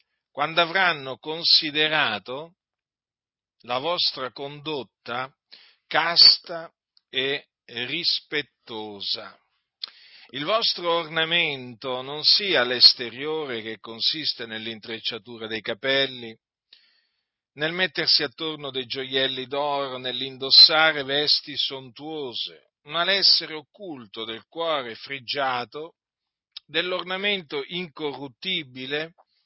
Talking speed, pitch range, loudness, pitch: 75 wpm, 125-160 Hz, -22 LUFS, 145 Hz